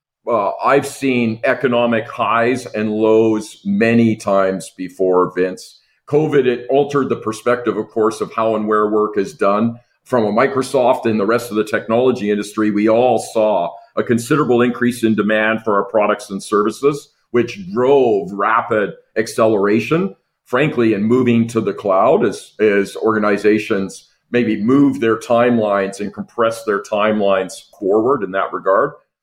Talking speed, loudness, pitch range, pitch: 150 wpm, -16 LUFS, 105-120 Hz, 110 Hz